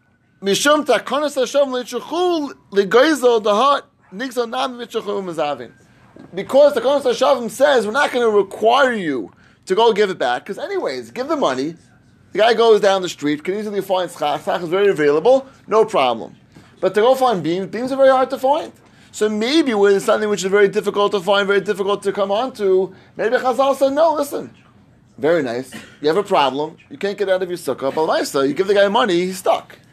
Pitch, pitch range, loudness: 210 Hz, 190-260 Hz, -17 LUFS